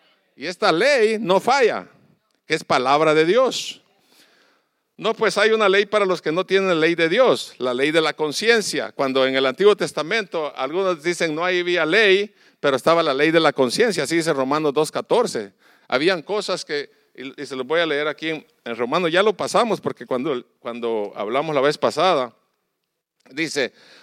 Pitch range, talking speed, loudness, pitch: 150-200 Hz, 180 wpm, -20 LUFS, 170 Hz